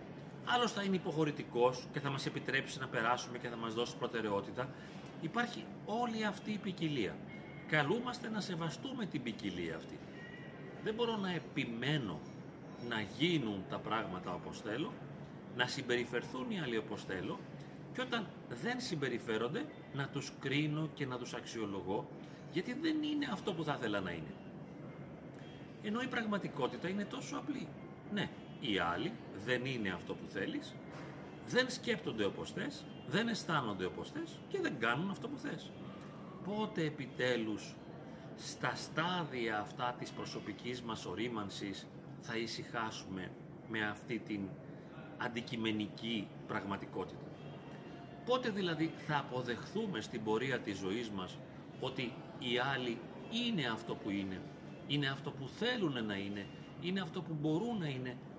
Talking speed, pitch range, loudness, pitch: 140 wpm, 120-190 Hz, -39 LUFS, 145 Hz